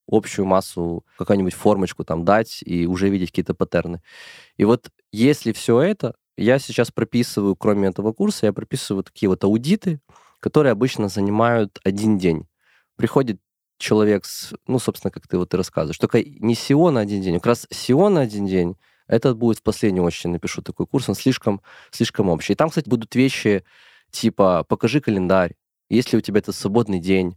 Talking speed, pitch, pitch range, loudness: 180 wpm, 105 Hz, 95-115 Hz, -20 LUFS